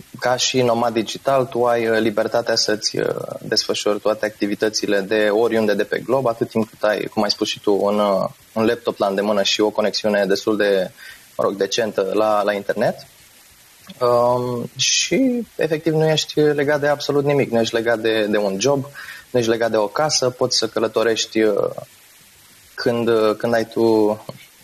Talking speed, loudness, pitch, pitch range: 170 wpm, -19 LUFS, 115 Hz, 105-125 Hz